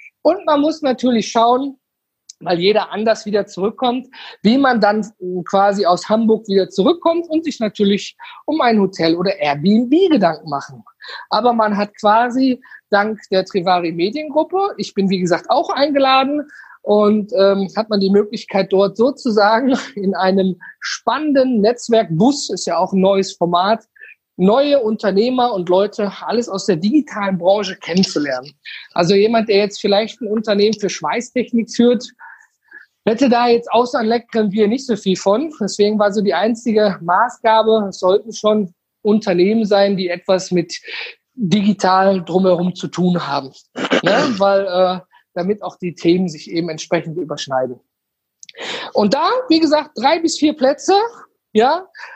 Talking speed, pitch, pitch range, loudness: 150 wpm, 210 Hz, 190-245 Hz, -16 LUFS